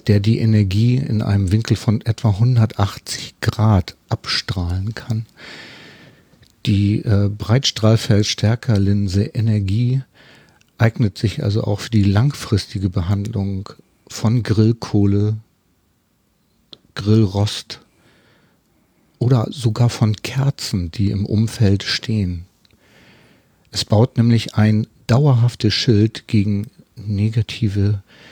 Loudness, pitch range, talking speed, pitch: -18 LUFS, 100-115 Hz, 90 wpm, 110 Hz